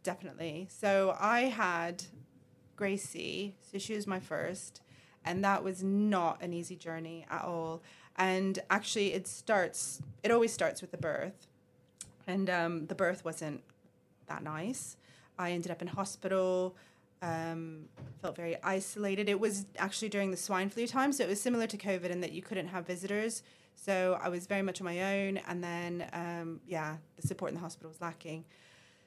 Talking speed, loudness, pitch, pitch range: 175 wpm, -35 LUFS, 185 Hz, 170-195 Hz